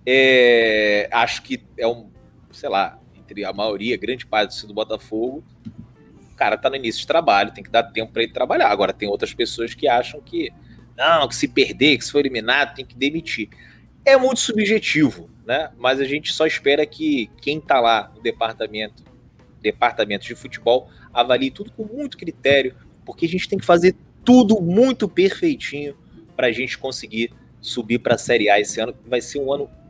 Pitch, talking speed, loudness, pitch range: 135 Hz, 185 wpm, -19 LUFS, 115-195 Hz